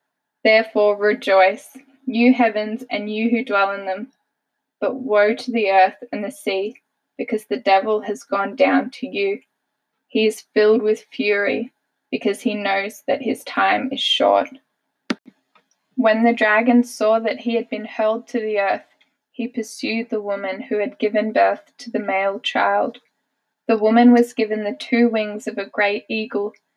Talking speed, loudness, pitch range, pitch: 165 wpm, -19 LUFS, 205-240 Hz, 220 Hz